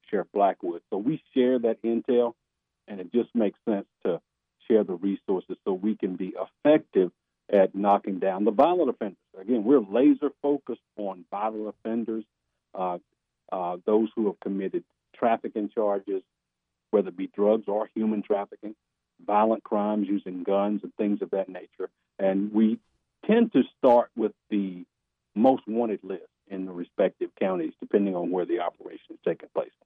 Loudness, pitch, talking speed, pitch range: -27 LUFS, 105 Hz, 160 wpm, 95-125 Hz